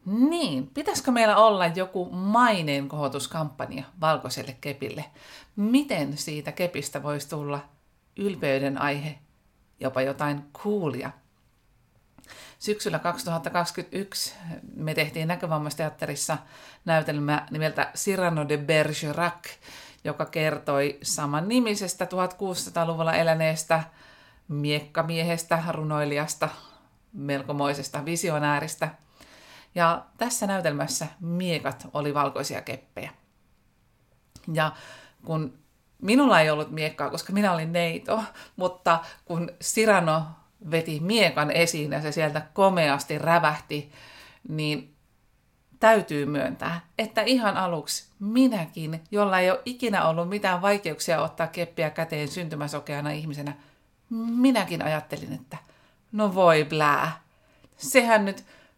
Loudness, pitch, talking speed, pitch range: -26 LUFS, 160 Hz, 95 wpm, 150-185 Hz